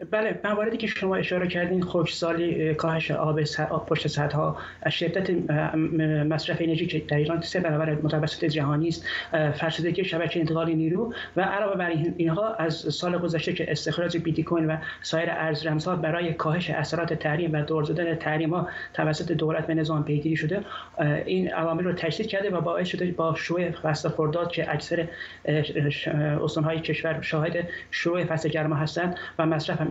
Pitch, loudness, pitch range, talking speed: 160 Hz, -26 LUFS, 155-175 Hz, 165 wpm